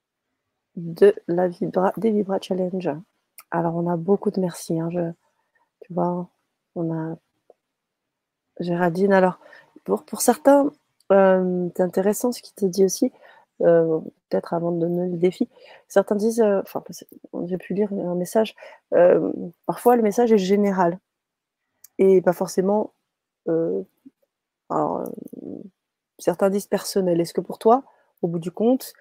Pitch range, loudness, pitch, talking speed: 175-220 Hz, -22 LUFS, 190 Hz, 145 wpm